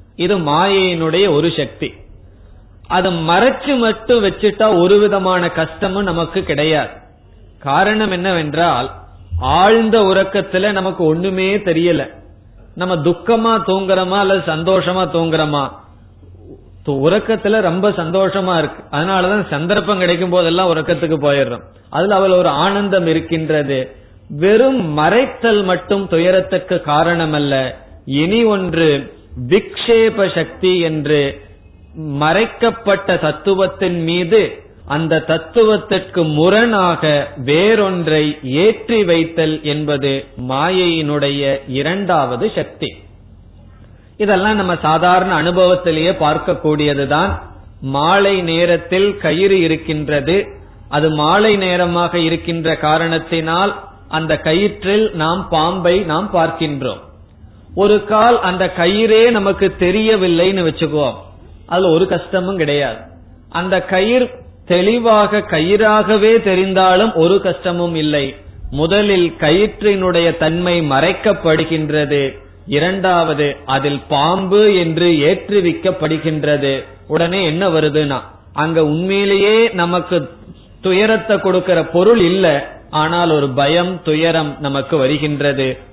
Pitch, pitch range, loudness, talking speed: 170 Hz, 150-190 Hz, -14 LUFS, 90 wpm